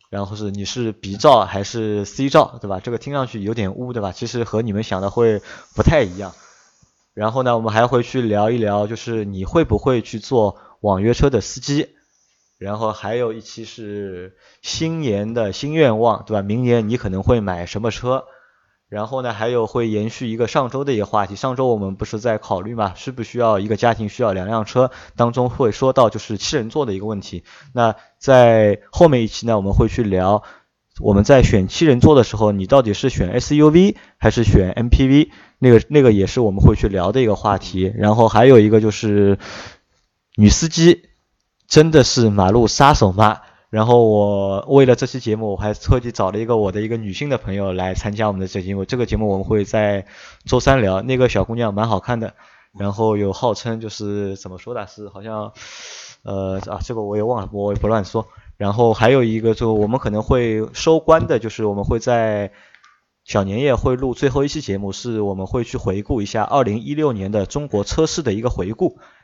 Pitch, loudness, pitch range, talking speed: 110 Hz, -17 LUFS, 100-125 Hz, 300 characters per minute